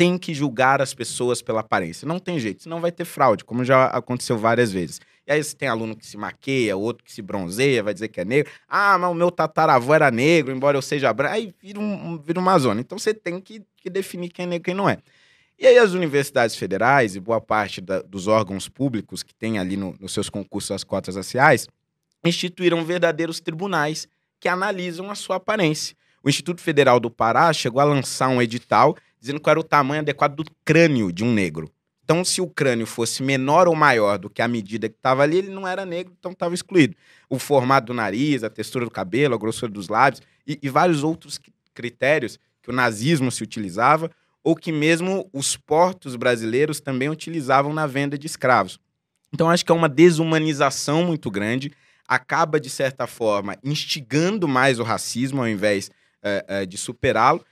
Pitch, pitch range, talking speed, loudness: 145 Hz, 120-165 Hz, 205 wpm, -21 LUFS